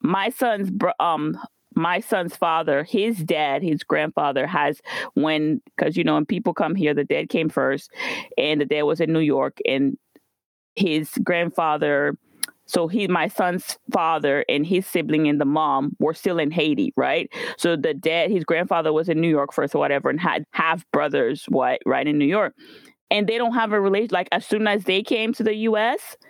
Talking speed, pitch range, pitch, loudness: 195 wpm, 155-210 Hz, 170 Hz, -22 LUFS